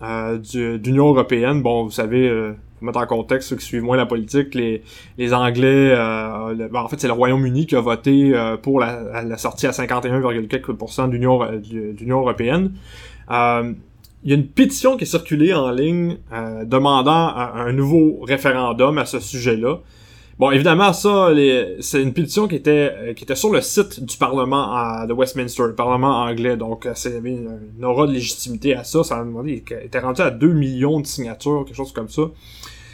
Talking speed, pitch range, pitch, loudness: 200 wpm, 115-140 Hz, 125 Hz, -18 LUFS